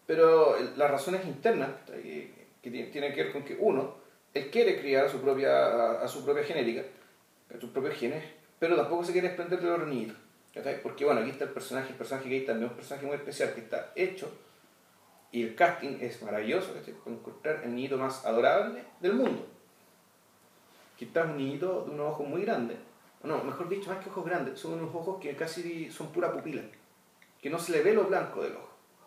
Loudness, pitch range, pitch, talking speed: -31 LUFS, 135-190 Hz, 165 Hz, 200 wpm